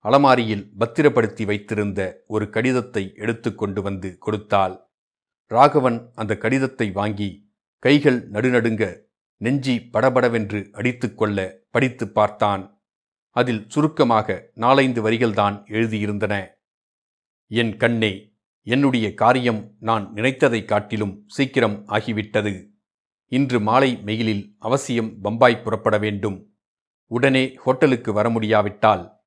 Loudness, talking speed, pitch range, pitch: -21 LUFS, 90 wpm, 105-125 Hz, 110 Hz